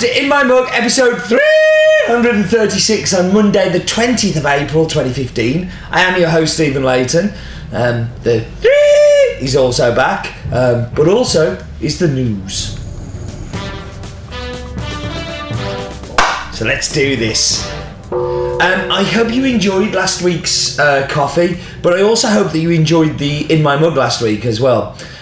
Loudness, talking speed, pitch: -13 LUFS, 140 wpm, 160 Hz